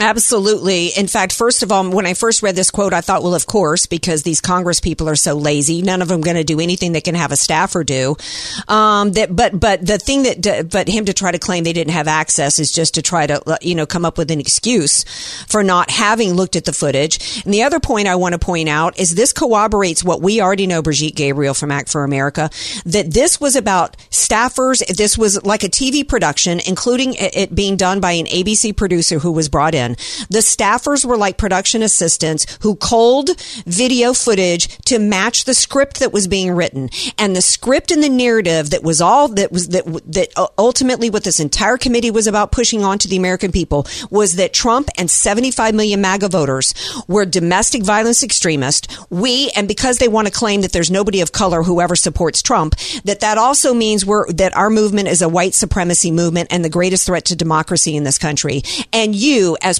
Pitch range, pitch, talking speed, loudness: 170-220 Hz, 190 Hz, 215 wpm, -14 LUFS